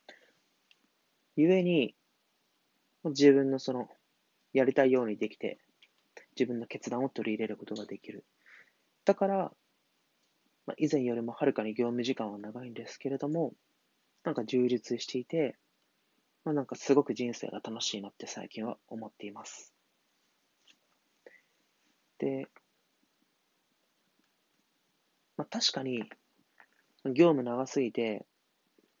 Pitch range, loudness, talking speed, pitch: 115-140 Hz, -31 LUFS, 215 characters per minute, 125 Hz